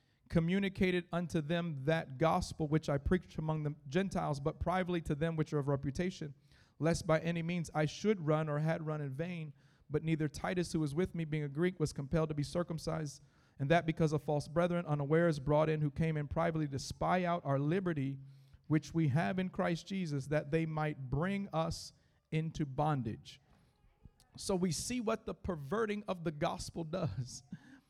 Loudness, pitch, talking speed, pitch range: -36 LUFS, 160 Hz, 185 wpm, 150-175 Hz